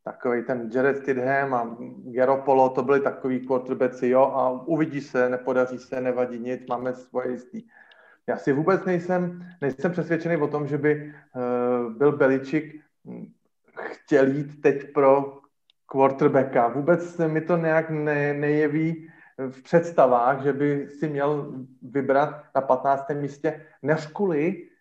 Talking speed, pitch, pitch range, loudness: 140 wpm, 140 Hz, 130-155 Hz, -24 LUFS